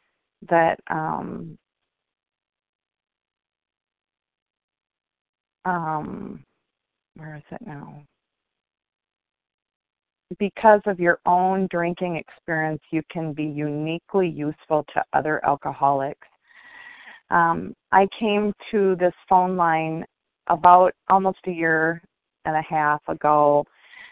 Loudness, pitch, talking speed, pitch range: -22 LUFS, 170 Hz, 90 wpm, 155-190 Hz